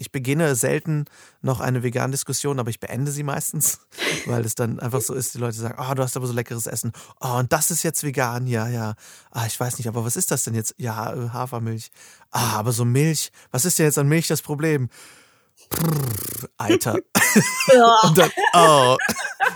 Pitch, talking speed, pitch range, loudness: 130 Hz, 195 wpm, 120-150 Hz, -21 LUFS